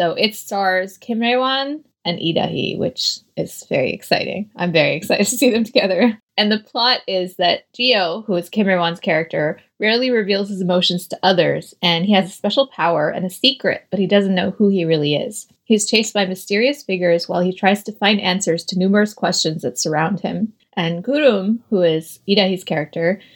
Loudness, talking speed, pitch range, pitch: -18 LUFS, 195 wpm, 175-220 Hz, 195 Hz